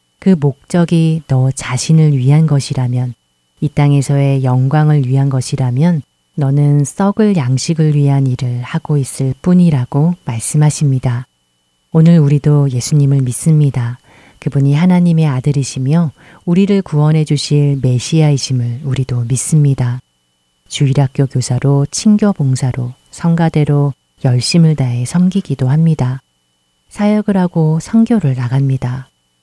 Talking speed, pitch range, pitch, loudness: 285 characters per minute, 130-160 Hz, 140 Hz, -13 LUFS